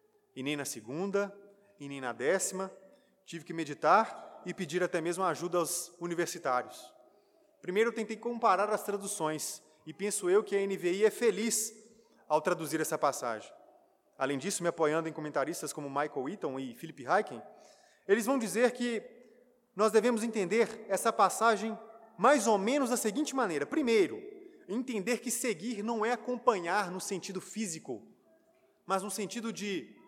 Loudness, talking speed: -32 LUFS, 155 wpm